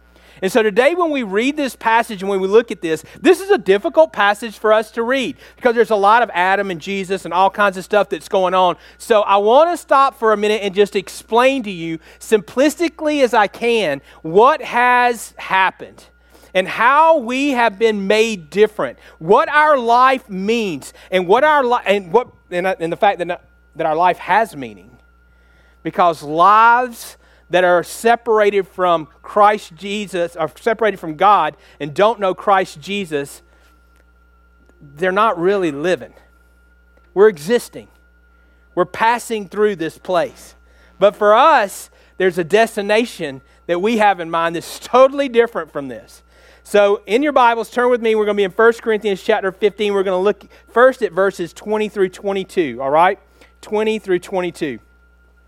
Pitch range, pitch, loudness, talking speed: 175-230 Hz, 205 Hz, -16 LUFS, 170 wpm